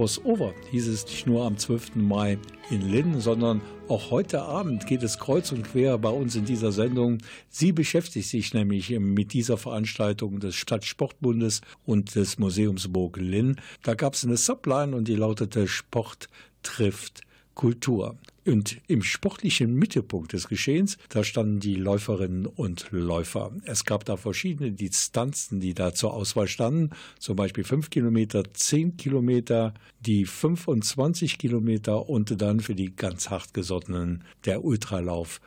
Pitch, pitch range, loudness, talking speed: 110 Hz, 100-125 Hz, -27 LUFS, 150 wpm